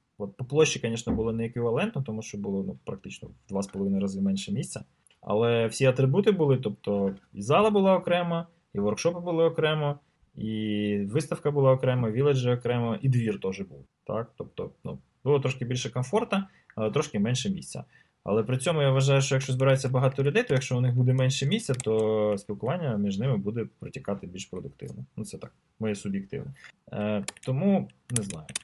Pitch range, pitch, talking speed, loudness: 105-145 Hz, 130 Hz, 175 wpm, -27 LUFS